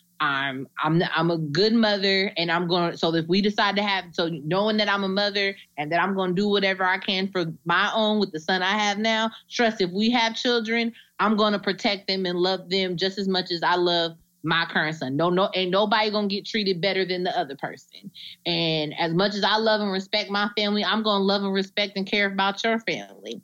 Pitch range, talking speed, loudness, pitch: 175-205 Hz, 245 wpm, -23 LUFS, 195 Hz